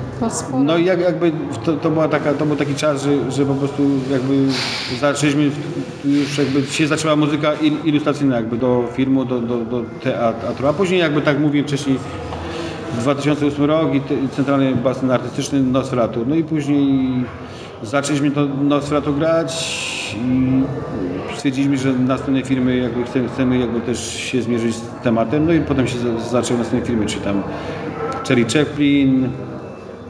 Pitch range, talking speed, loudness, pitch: 125-150 Hz, 155 wpm, -18 LUFS, 135 Hz